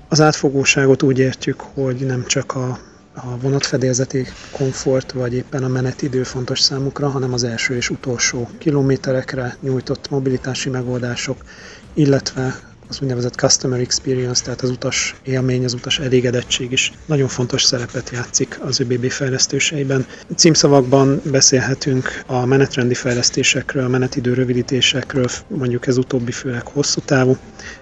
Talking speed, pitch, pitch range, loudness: 130 wpm, 130 Hz, 125-135 Hz, -17 LUFS